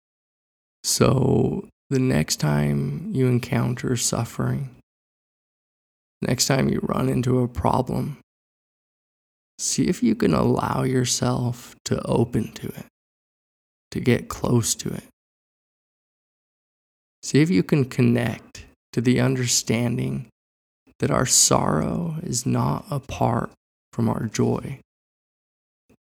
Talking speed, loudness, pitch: 105 wpm, -22 LUFS, 120 Hz